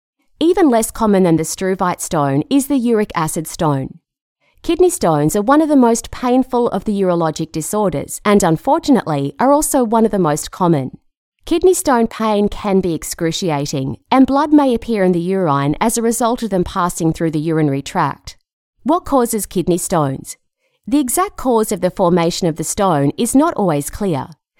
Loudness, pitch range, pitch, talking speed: -16 LUFS, 165-250 Hz, 195 Hz, 180 wpm